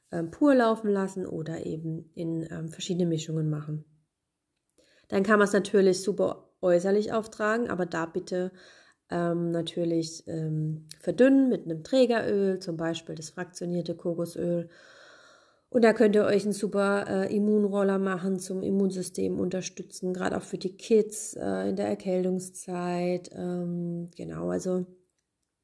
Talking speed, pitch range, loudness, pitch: 135 wpm, 165-200 Hz, -28 LUFS, 180 Hz